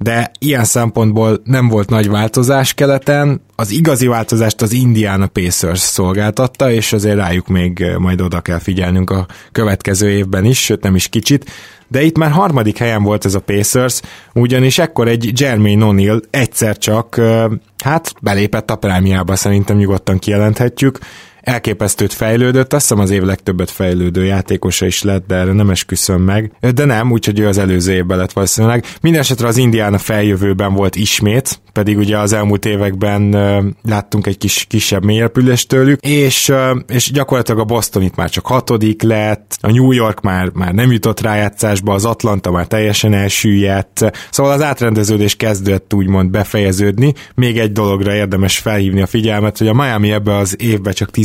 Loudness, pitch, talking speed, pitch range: -13 LUFS, 105 Hz, 165 wpm, 100-120 Hz